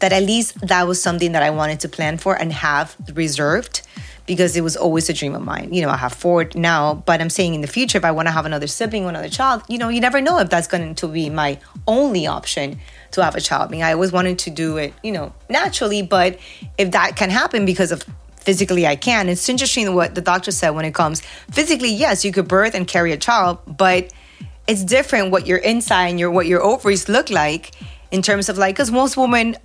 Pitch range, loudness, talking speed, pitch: 165-210 Hz, -18 LUFS, 245 wpm, 180 Hz